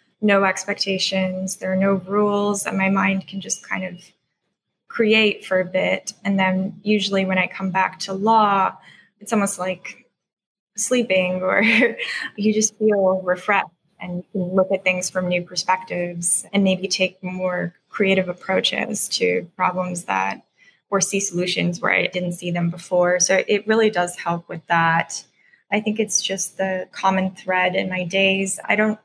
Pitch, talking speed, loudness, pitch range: 190 Hz, 165 wpm, -20 LUFS, 180-205 Hz